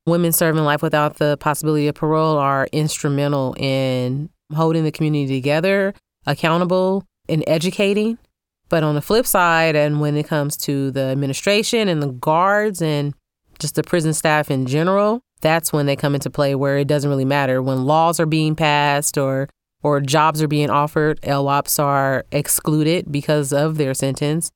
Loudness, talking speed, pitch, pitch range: -18 LUFS, 170 wpm, 150 Hz, 145-160 Hz